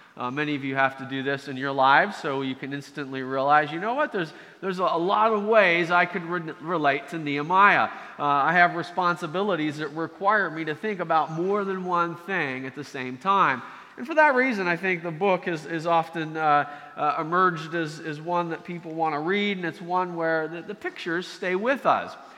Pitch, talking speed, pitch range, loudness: 165 Hz, 220 wpm, 150-185 Hz, -24 LUFS